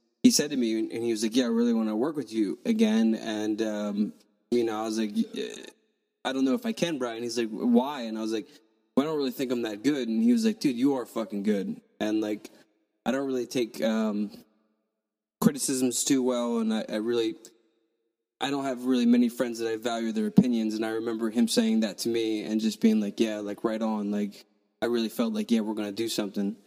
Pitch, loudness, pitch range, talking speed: 115 Hz, -28 LUFS, 110-130 Hz, 240 wpm